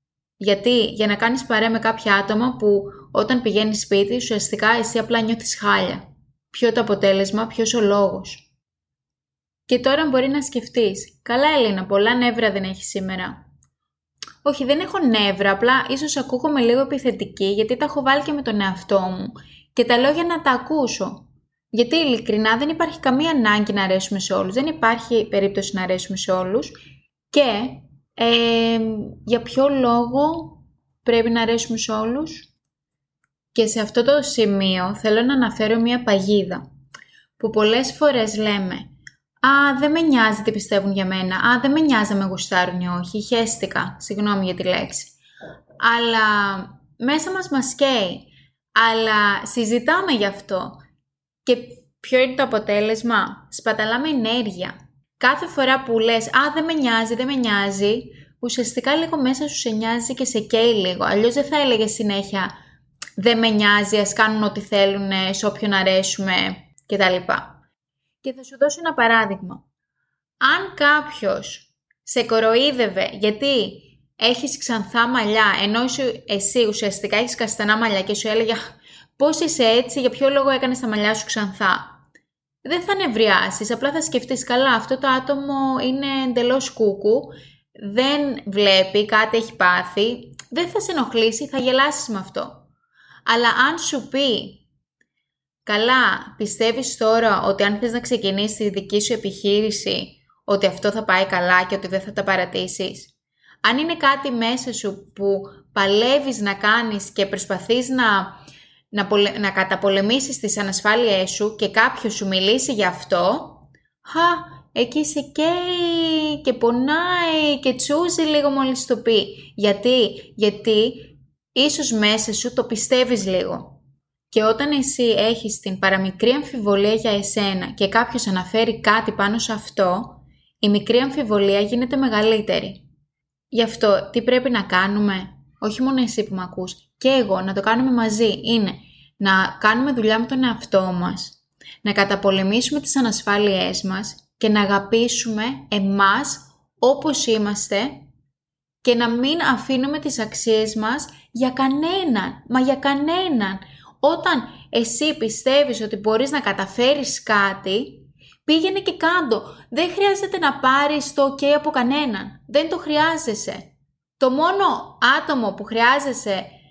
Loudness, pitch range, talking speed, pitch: -19 LUFS, 200-260 Hz, 145 wpm, 225 Hz